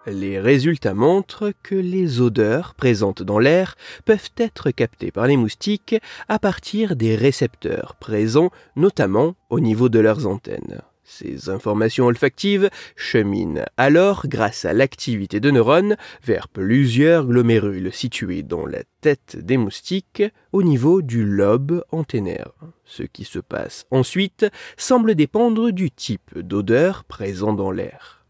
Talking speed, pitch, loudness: 135 wpm, 140 Hz, -19 LUFS